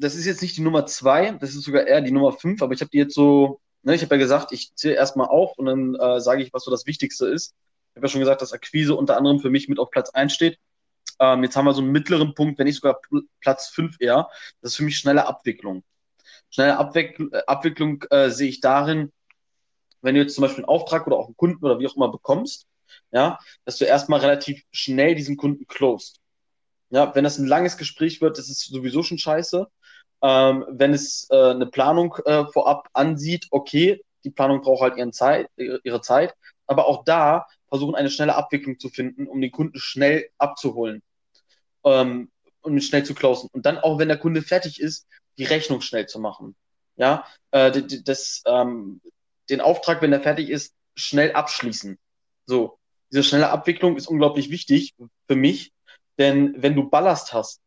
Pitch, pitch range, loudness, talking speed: 140 Hz, 135-155 Hz, -21 LUFS, 205 wpm